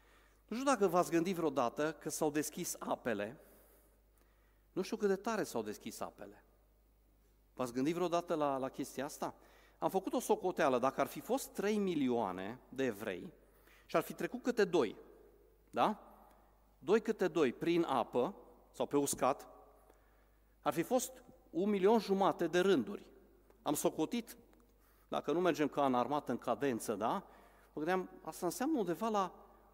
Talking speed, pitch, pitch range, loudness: 155 wpm, 170 Hz, 140-205 Hz, -36 LUFS